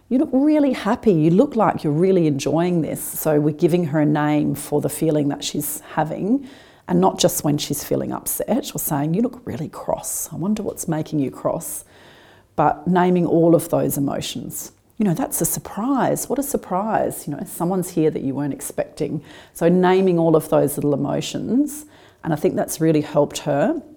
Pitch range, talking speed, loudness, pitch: 150-210 Hz, 195 wpm, -20 LUFS, 170 Hz